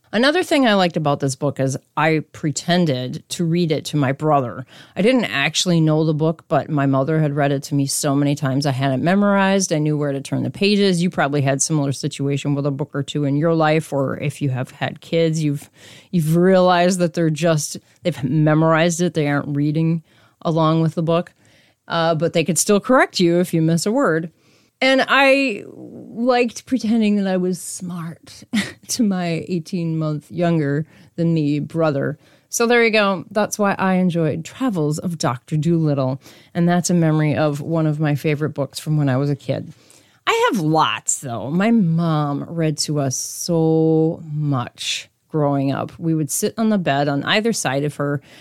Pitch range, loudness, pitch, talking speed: 145-175 Hz, -19 LUFS, 160 Hz, 200 wpm